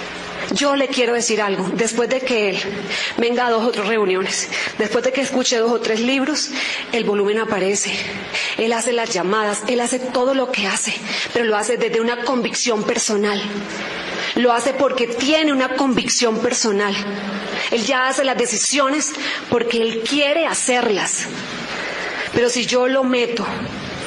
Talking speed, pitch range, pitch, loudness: 160 wpm, 215-255 Hz, 235 Hz, -19 LUFS